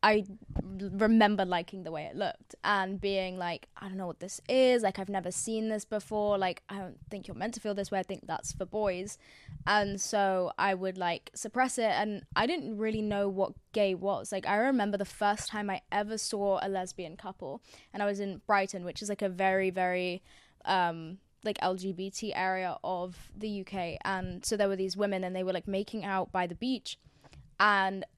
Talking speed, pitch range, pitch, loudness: 210 wpm, 185-210 Hz, 195 Hz, -32 LUFS